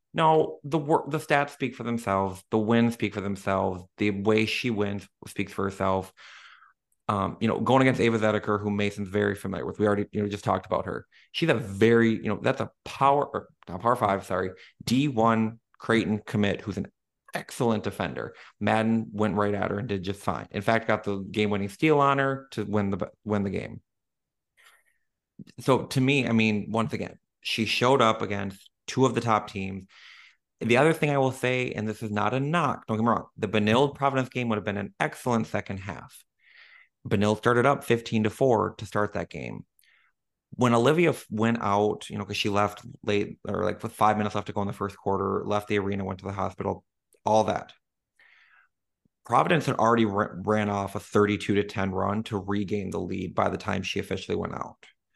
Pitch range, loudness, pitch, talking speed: 100-115 Hz, -26 LUFS, 105 Hz, 205 wpm